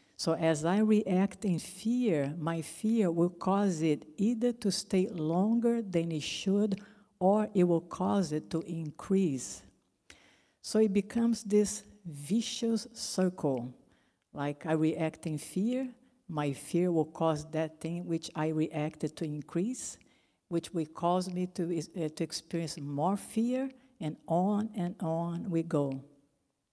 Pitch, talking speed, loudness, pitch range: 175 Hz, 140 wpm, -32 LUFS, 155-205 Hz